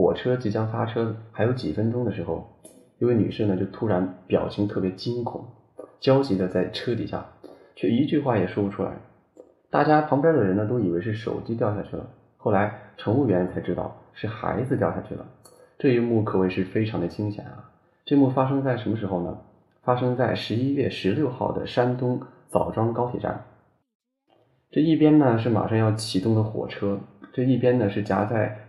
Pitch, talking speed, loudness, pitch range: 110 Hz, 280 characters per minute, -24 LUFS, 100-125 Hz